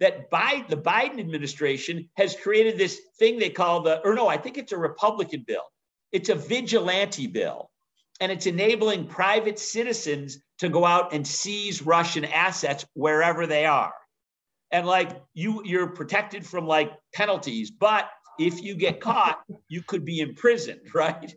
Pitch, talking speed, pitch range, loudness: 185 Hz, 160 wpm, 165-220 Hz, -25 LUFS